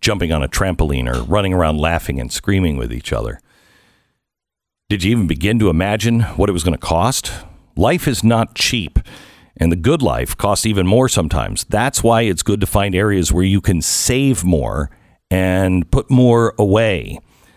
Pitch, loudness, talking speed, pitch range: 95 Hz, -16 LUFS, 180 wpm, 85-110 Hz